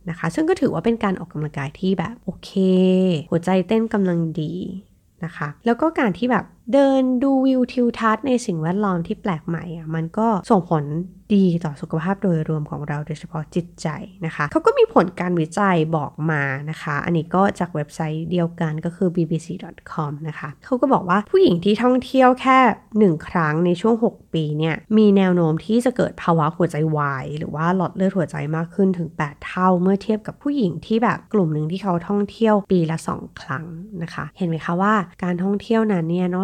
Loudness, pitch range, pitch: -20 LUFS, 160-215 Hz, 180 Hz